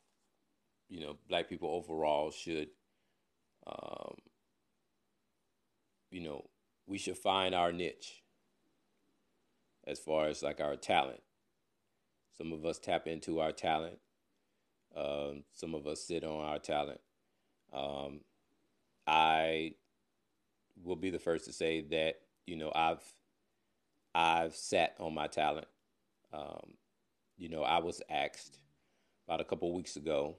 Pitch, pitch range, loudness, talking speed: 80 Hz, 75-85 Hz, -36 LUFS, 125 wpm